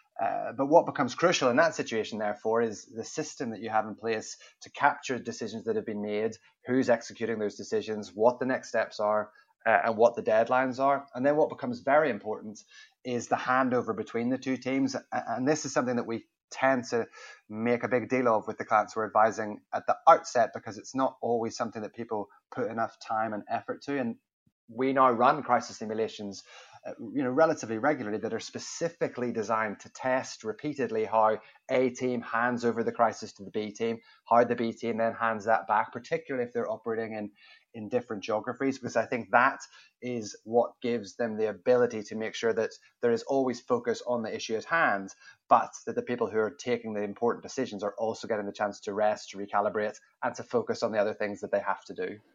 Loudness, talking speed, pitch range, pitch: -29 LUFS, 210 wpm, 110-130 Hz, 115 Hz